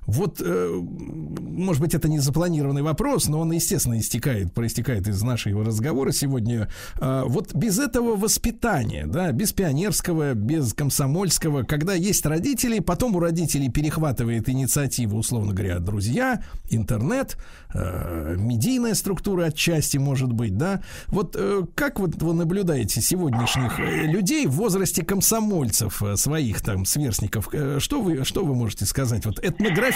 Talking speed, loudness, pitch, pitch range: 130 wpm, -23 LUFS, 145 Hz, 115-175 Hz